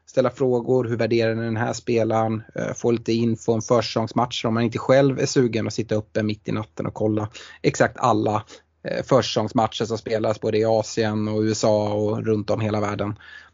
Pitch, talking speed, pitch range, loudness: 110 Hz, 190 wpm, 110-120 Hz, -22 LUFS